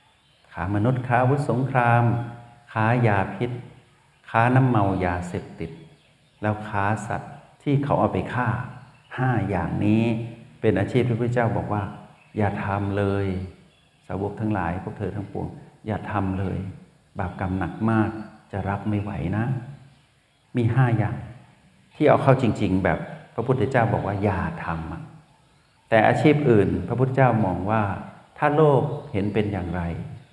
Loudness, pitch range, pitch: -23 LUFS, 100-125 Hz, 110 Hz